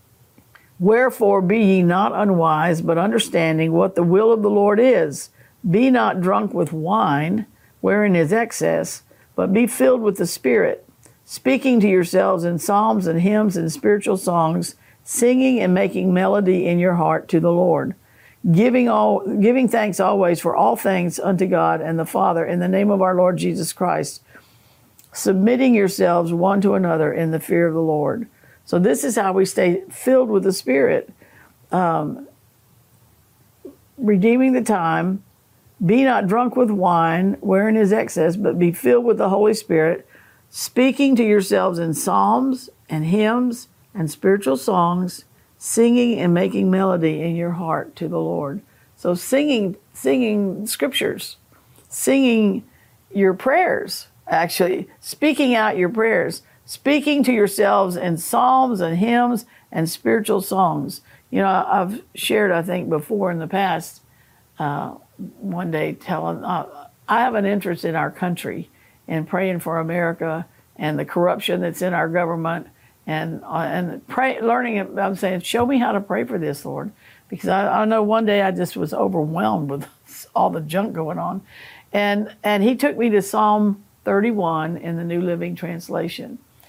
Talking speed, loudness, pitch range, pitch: 160 wpm, -19 LUFS, 170-220 Hz, 190 Hz